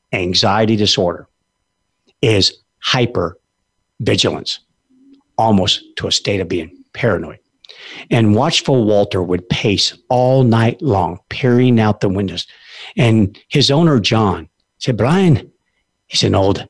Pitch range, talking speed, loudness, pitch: 100-145 Hz, 120 wpm, -15 LUFS, 115 Hz